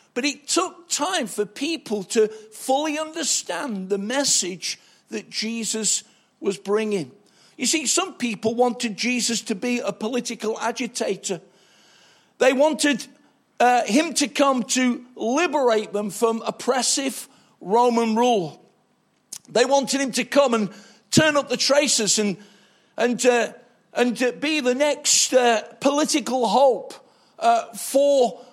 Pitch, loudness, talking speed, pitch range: 245 Hz, -21 LUFS, 130 wpm, 220-275 Hz